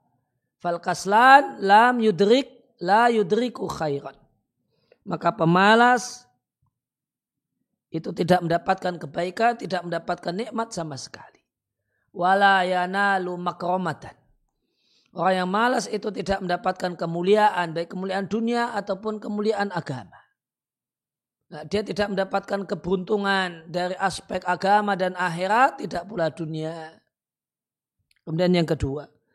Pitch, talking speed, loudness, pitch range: 185 Hz, 95 wpm, -23 LUFS, 170-210 Hz